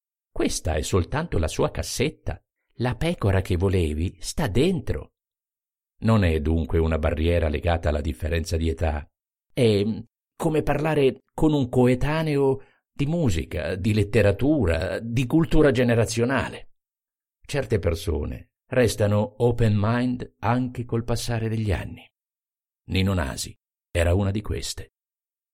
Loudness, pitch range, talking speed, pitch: -24 LUFS, 85-125 Hz, 120 wpm, 105 Hz